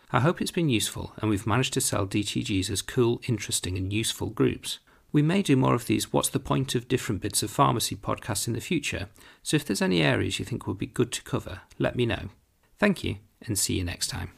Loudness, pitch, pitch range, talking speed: -27 LUFS, 110 Hz, 100-130 Hz, 240 wpm